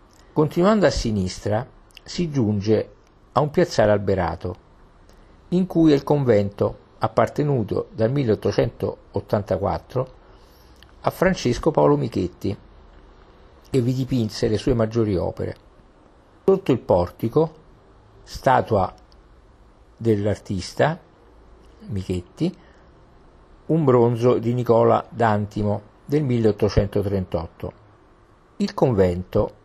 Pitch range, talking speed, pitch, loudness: 90-125 Hz, 85 wpm, 105 Hz, -22 LUFS